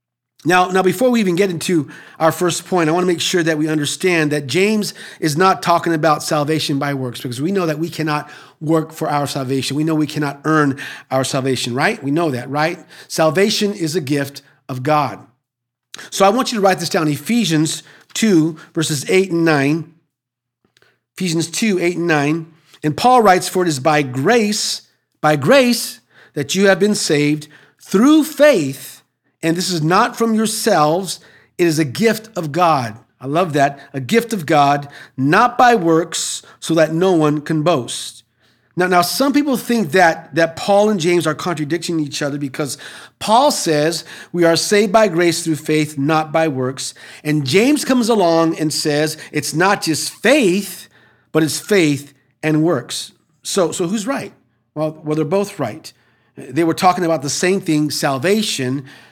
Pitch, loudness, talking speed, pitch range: 160 Hz, -16 LUFS, 180 wpm, 150-185 Hz